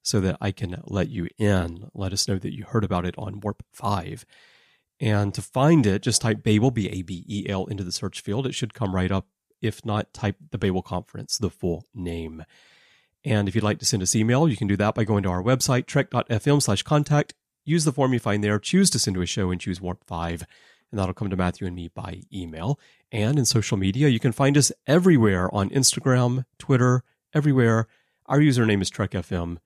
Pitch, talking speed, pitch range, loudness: 105 Hz, 220 wpm, 95-125 Hz, -24 LUFS